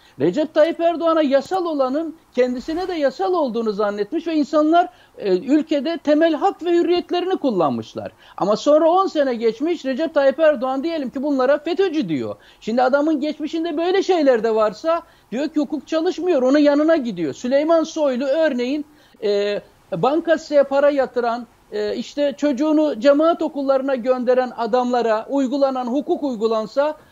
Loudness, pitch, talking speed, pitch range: -19 LUFS, 290 Hz, 140 wpm, 260-325 Hz